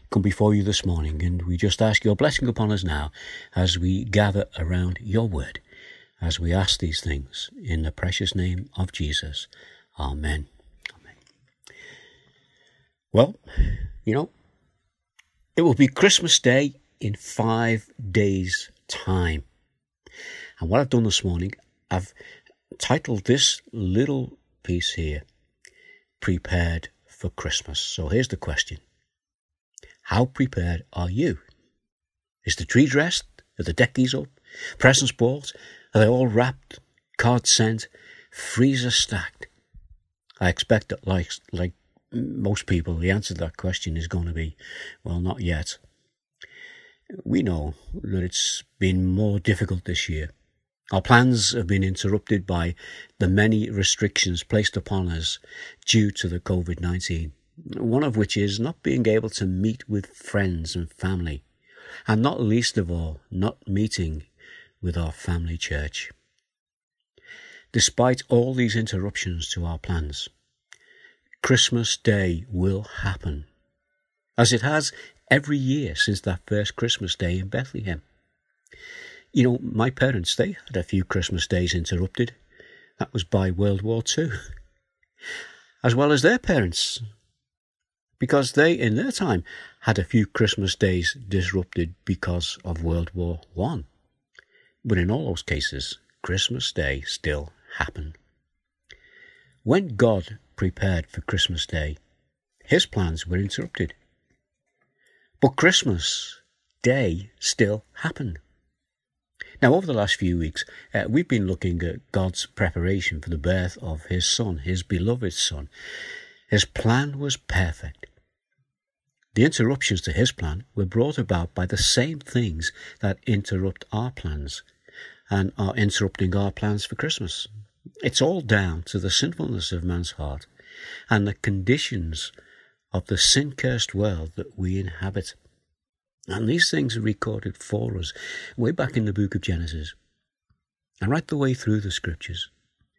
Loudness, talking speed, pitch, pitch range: -24 LUFS, 140 wpm, 100 Hz, 90-120 Hz